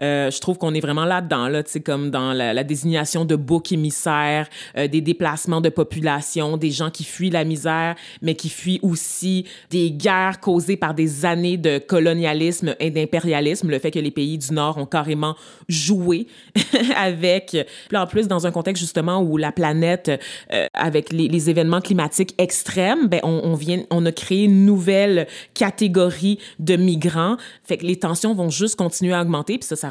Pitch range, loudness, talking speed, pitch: 155-185 Hz, -20 LUFS, 185 wpm, 170 Hz